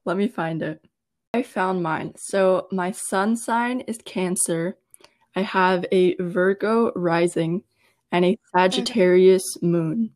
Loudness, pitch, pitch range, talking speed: -22 LUFS, 185 Hz, 180-200 Hz, 130 wpm